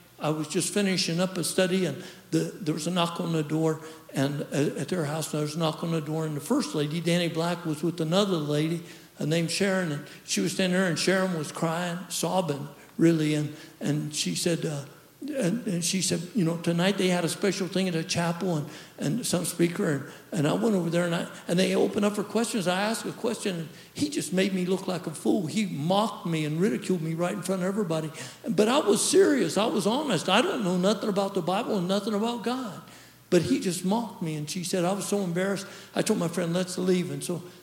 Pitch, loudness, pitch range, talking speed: 180 Hz, -27 LUFS, 160-190 Hz, 240 wpm